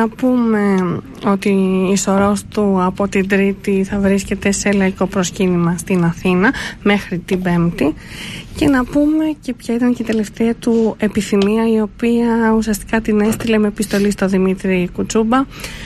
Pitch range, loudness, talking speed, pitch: 190-225 Hz, -16 LUFS, 150 wpm, 205 Hz